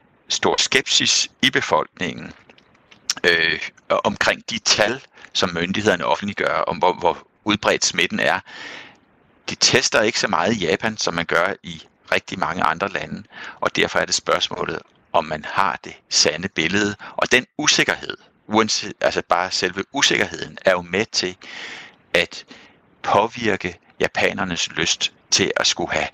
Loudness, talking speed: -19 LUFS, 145 wpm